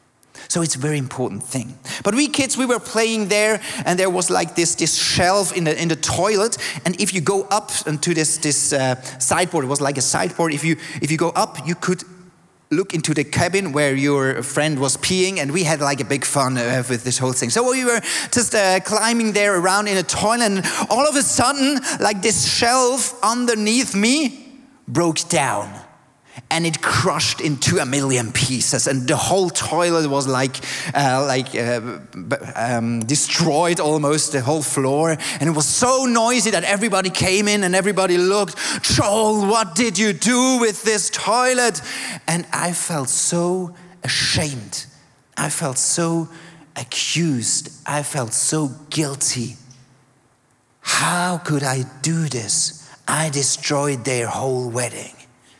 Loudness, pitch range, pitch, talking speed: -18 LUFS, 140-200 Hz, 160 Hz, 170 wpm